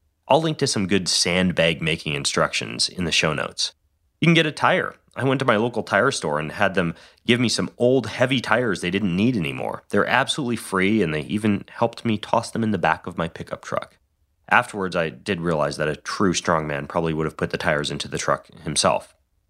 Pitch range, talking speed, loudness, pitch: 80-115 Hz, 220 wpm, -22 LUFS, 95 Hz